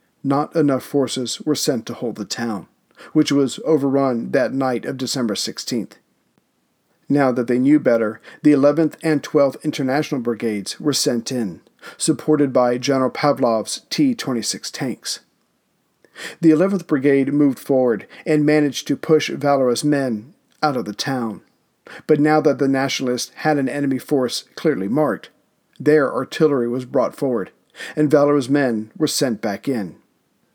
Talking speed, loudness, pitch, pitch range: 150 wpm, -19 LUFS, 140 Hz, 125-150 Hz